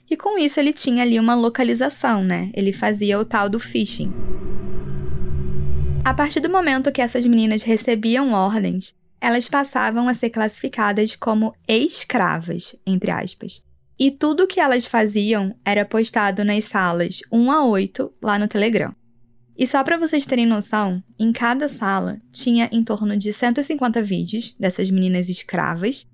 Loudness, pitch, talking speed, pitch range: -20 LUFS, 220 Hz, 155 wpm, 195-250 Hz